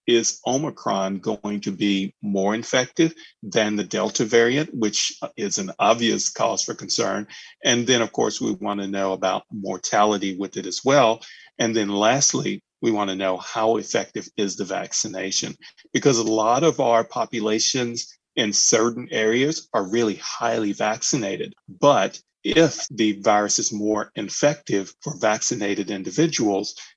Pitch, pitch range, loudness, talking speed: 110 Hz, 100-120 Hz, -22 LUFS, 150 wpm